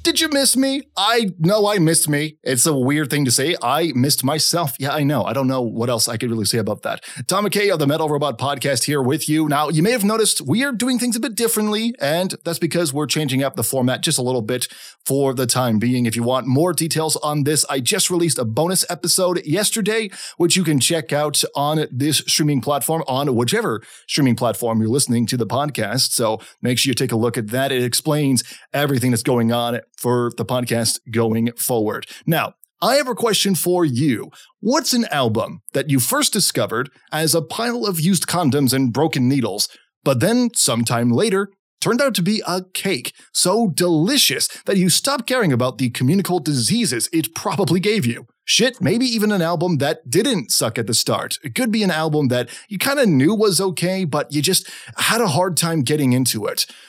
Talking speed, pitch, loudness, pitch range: 215 wpm, 150 Hz, -18 LUFS, 130-190 Hz